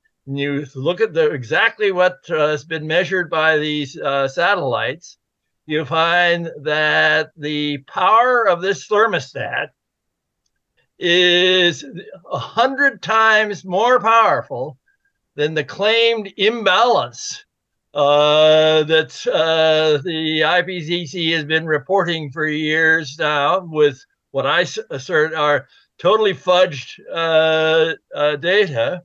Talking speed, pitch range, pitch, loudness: 110 wpm, 150-200 Hz, 160 Hz, -17 LUFS